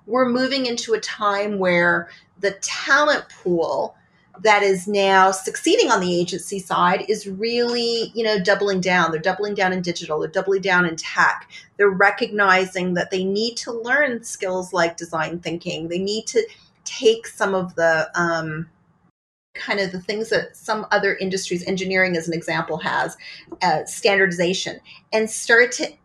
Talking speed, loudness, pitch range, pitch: 160 wpm, -20 LUFS, 175-220 Hz, 195 Hz